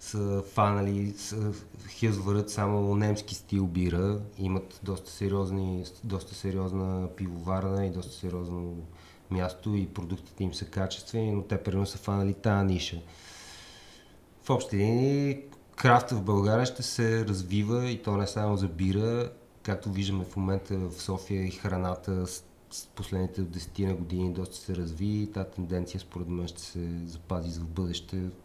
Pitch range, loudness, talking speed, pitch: 90-105 Hz, -31 LUFS, 150 wpm, 95 Hz